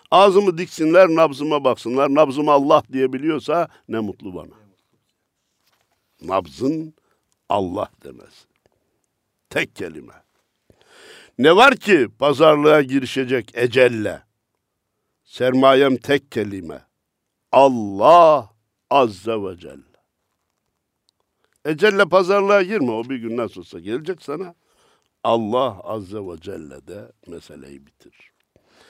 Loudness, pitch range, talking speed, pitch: -17 LUFS, 115-160 Hz, 95 wpm, 135 Hz